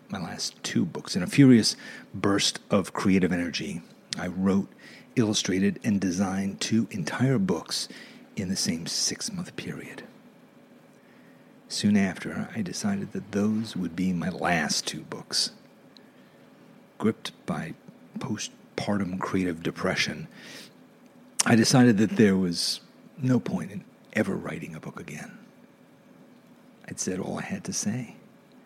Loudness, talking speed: -26 LUFS, 130 wpm